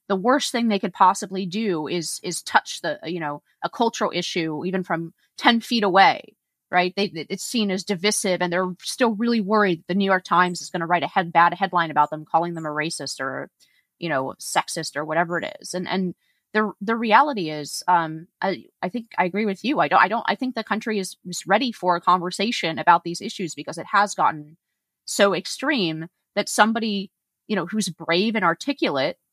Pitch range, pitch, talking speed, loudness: 170-210 Hz, 185 Hz, 210 wpm, -22 LUFS